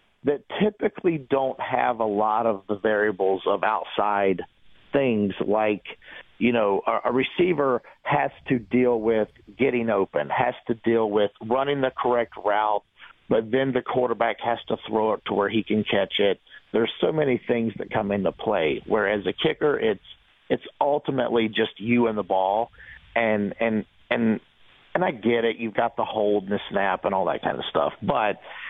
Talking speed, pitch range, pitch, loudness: 180 wpm, 105-125 Hz, 115 Hz, -24 LUFS